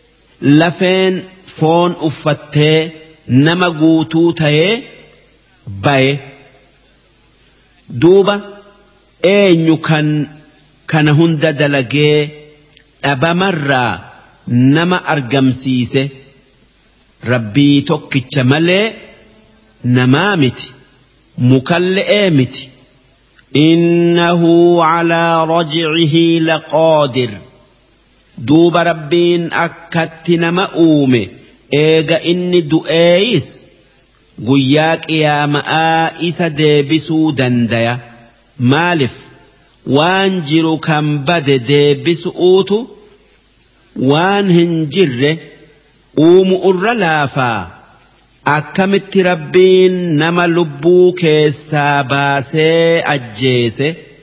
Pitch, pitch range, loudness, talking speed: 155 Hz, 140-170 Hz, -12 LUFS, 60 wpm